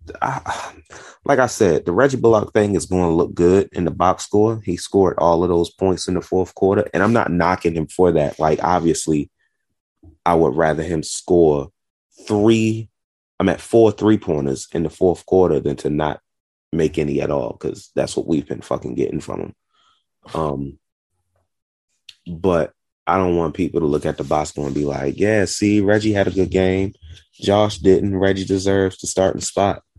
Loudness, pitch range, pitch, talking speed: -18 LUFS, 80-100 Hz, 90 Hz, 190 wpm